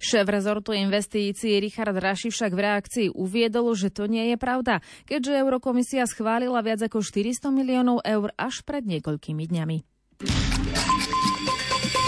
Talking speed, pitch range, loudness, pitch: 130 wpm, 205-250 Hz, -25 LUFS, 220 Hz